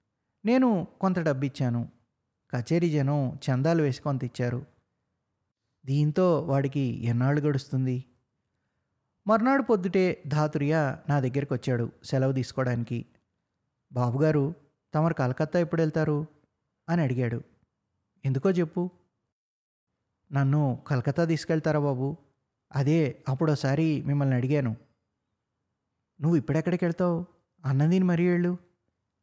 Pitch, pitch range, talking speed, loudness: 140 Hz, 125-165 Hz, 90 wpm, -27 LUFS